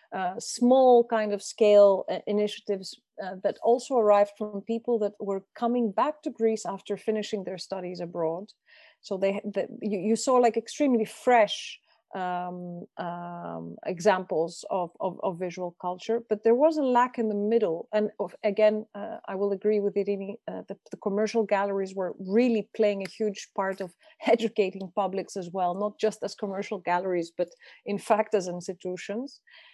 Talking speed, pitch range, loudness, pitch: 165 wpm, 190-225 Hz, -27 LUFS, 205 Hz